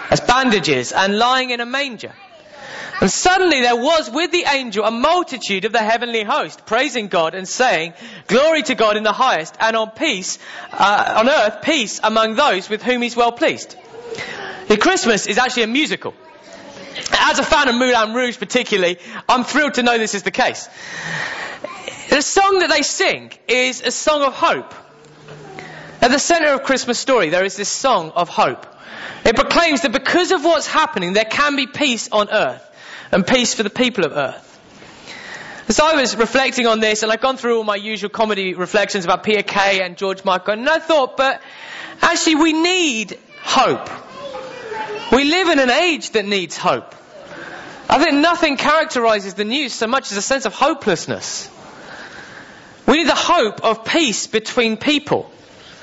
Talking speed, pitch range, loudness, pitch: 175 wpm, 215-300 Hz, -16 LUFS, 250 Hz